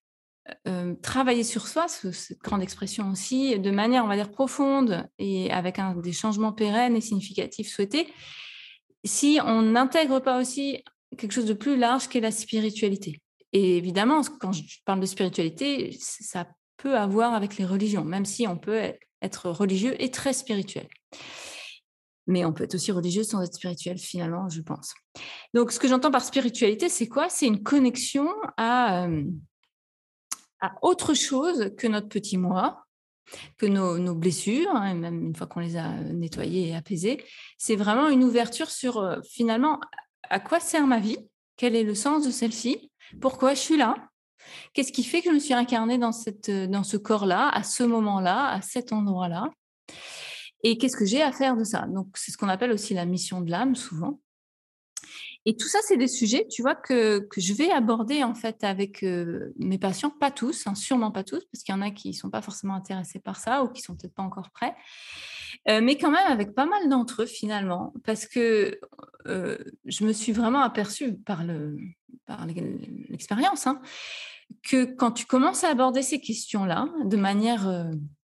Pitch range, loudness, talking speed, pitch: 195-260 Hz, -26 LUFS, 190 wpm, 225 Hz